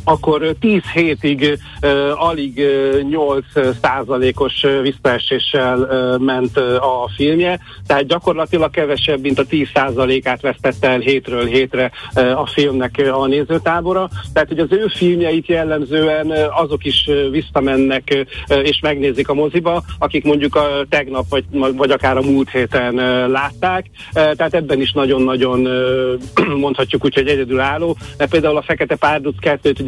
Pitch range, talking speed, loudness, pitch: 130-155 Hz, 155 wpm, -15 LUFS, 140 Hz